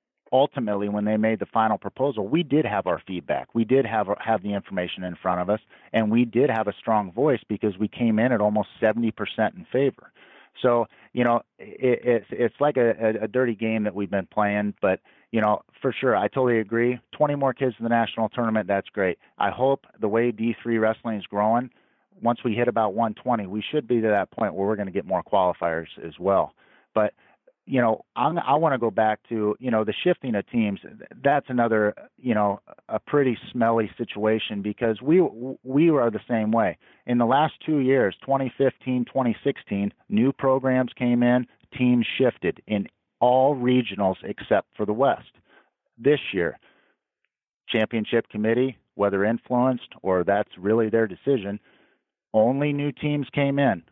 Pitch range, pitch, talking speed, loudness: 105-130 Hz, 115 Hz, 185 wpm, -24 LUFS